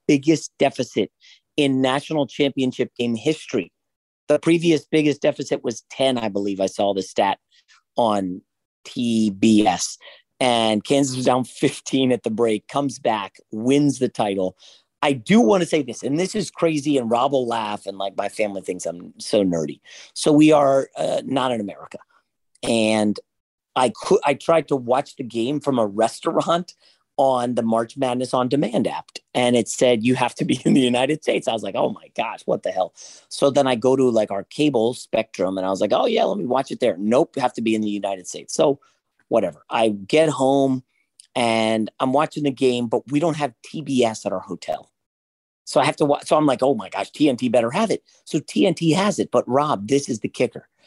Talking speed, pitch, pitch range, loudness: 205 wpm, 130 Hz, 110-145 Hz, -21 LUFS